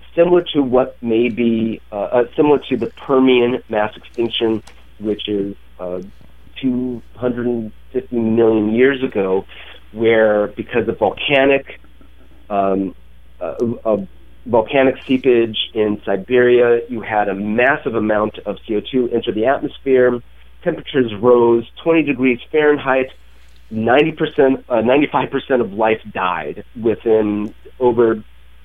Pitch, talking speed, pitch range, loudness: 115 Hz, 115 wpm, 105-125 Hz, -17 LUFS